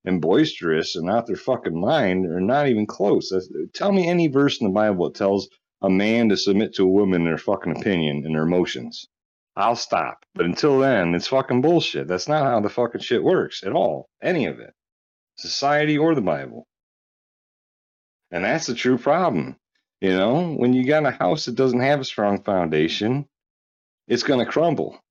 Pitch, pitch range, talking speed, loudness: 110 Hz, 95-140 Hz, 195 wpm, -21 LUFS